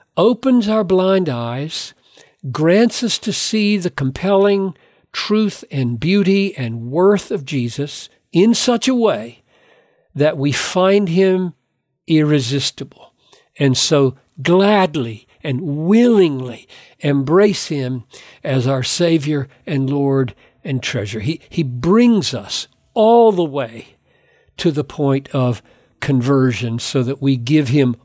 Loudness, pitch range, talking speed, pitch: -16 LUFS, 130-195 Hz, 120 wpm, 150 Hz